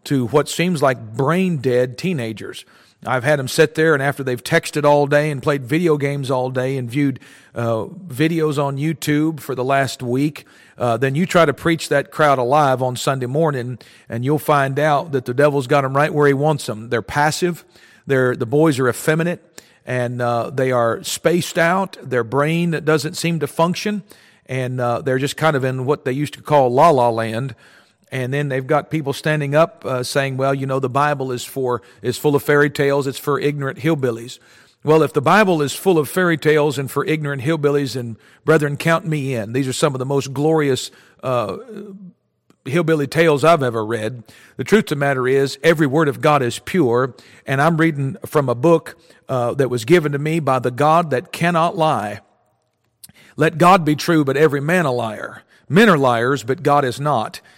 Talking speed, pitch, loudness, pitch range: 205 wpm, 145 Hz, -18 LUFS, 130-155 Hz